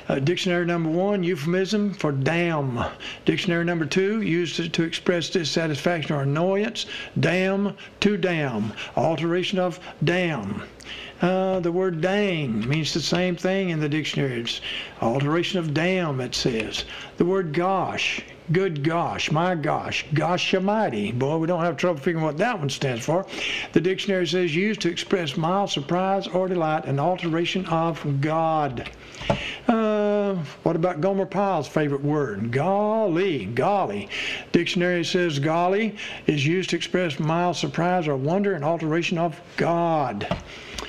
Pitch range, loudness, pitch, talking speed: 155-185 Hz, -24 LUFS, 170 Hz, 145 wpm